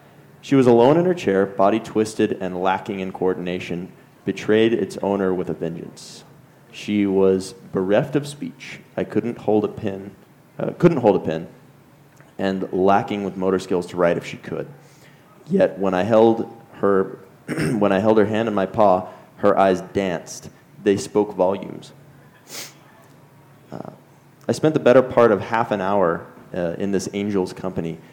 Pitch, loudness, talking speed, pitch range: 100 Hz, -20 LUFS, 165 wpm, 95-110 Hz